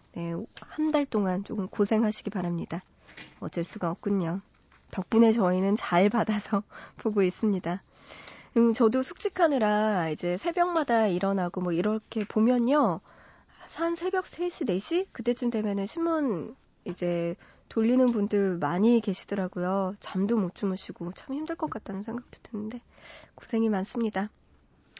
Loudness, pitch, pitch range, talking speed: -28 LUFS, 210 Hz, 185-240 Hz, 285 characters per minute